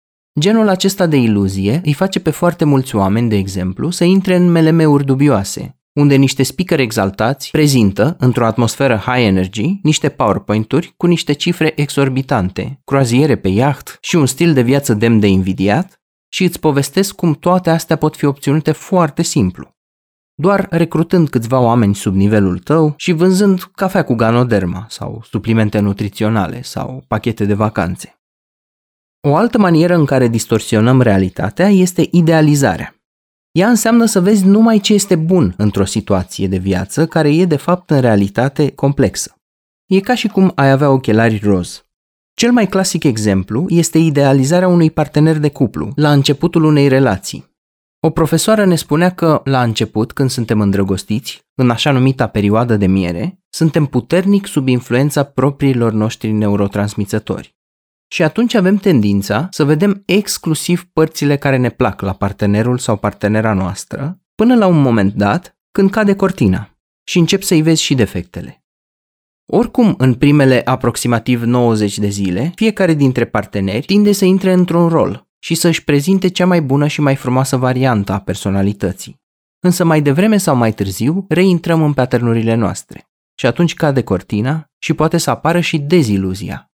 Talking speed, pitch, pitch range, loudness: 155 wpm, 140 Hz, 110-170 Hz, -13 LUFS